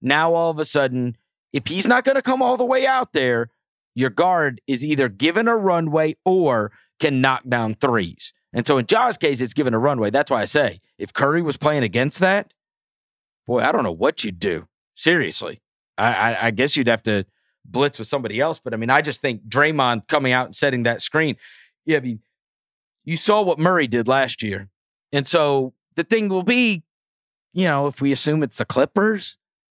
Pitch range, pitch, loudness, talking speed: 125-170 Hz, 145 Hz, -20 LUFS, 210 wpm